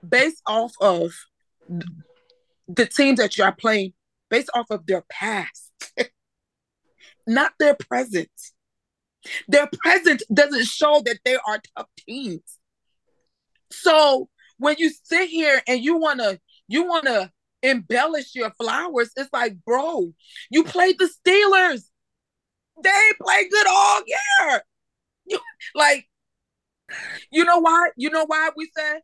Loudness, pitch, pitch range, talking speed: -19 LUFS, 290 Hz, 230-335 Hz, 125 wpm